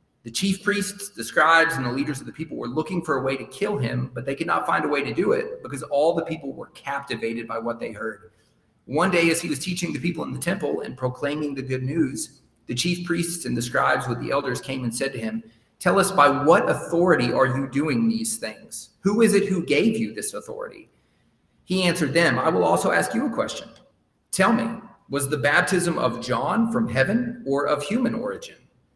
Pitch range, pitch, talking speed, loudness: 135-200 Hz, 165 Hz, 230 wpm, -23 LUFS